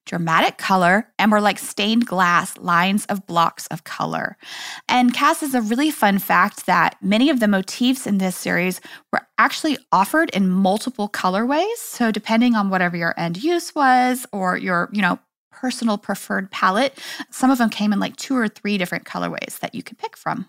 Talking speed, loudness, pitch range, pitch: 185 wpm, -19 LUFS, 190-255 Hz, 210 Hz